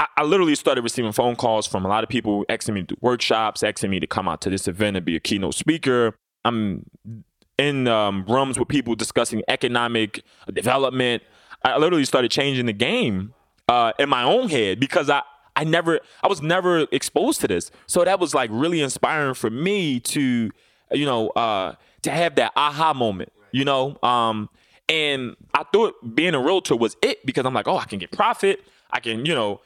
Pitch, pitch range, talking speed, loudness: 125 Hz, 110-150 Hz, 200 wpm, -21 LUFS